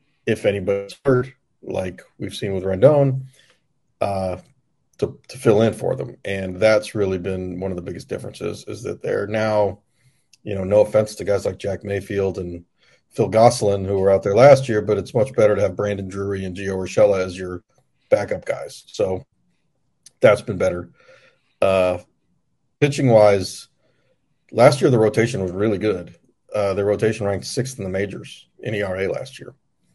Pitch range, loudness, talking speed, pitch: 95-110 Hz, -20 LUFS, 175 wpm, 100 Hz